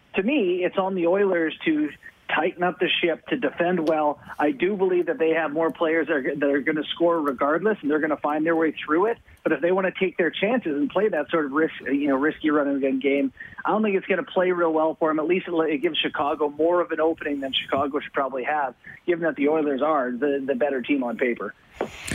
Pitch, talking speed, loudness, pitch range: 160 Hz, 250 wpm, -23 LUFS, 150-175 Hz